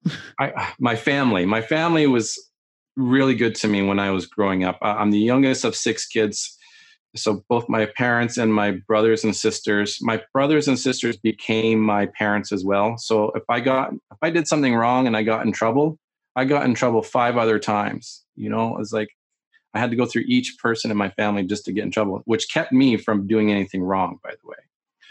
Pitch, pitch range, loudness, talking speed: 110 Hz, 105-125 Hz, -21 LUFS, 215 wpm